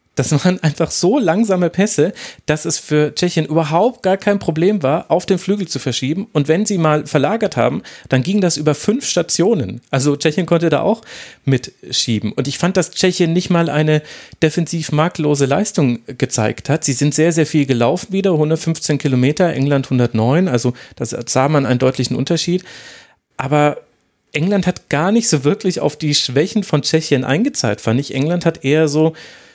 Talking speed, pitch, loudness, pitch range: 180 wpm, 155 Hz, -16 LUFS, 140-175 Hz